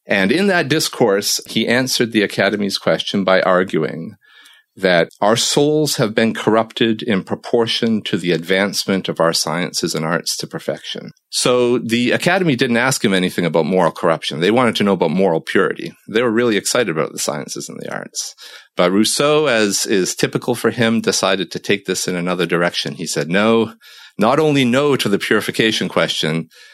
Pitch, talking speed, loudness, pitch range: 110 Hz, 180 wpm, -17 LUFS, 95-125 Hz